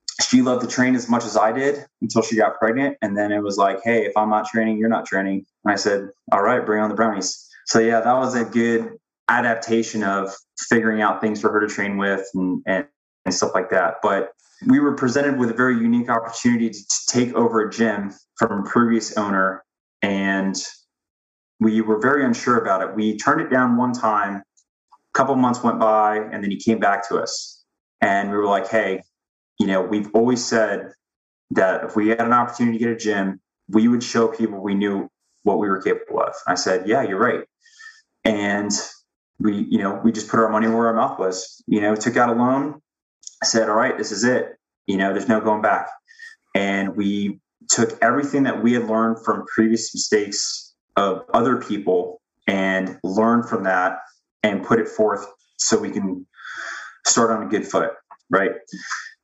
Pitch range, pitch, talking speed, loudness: 100-120 Hz, 110 Hz, 205 wpm, -20 LUFS